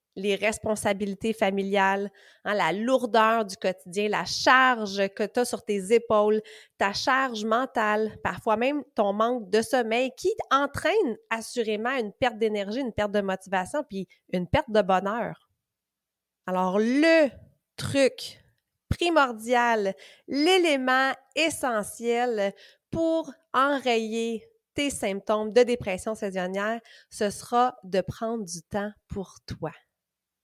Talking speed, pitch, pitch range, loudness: 120 wpm, 225 Hz, 205-255 Hz, -26 LUFS